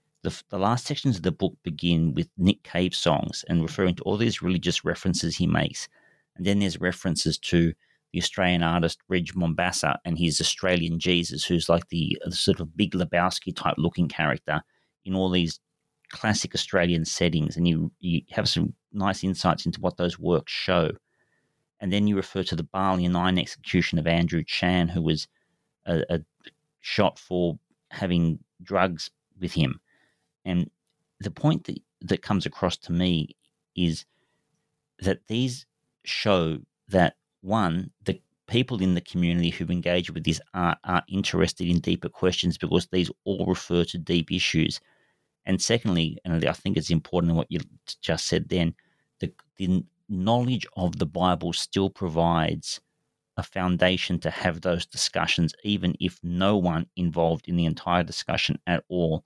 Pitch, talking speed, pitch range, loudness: 90 Hz, 165 wpm, 85-95 Hz, -26 LUFS